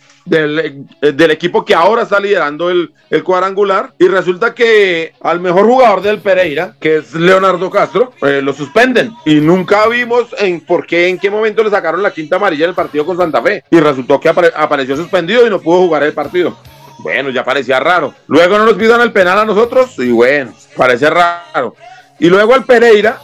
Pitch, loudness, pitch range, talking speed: 180 Hz, -11 LUFS, 155-215 Hz, 195 wpm